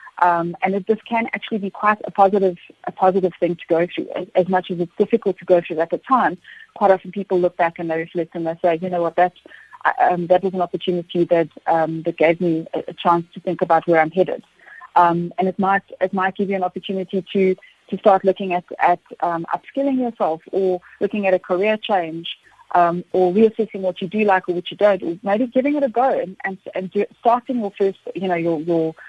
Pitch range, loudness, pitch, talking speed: 175-200 Hz, -20 LUFS, 185 Hz, 235 wpm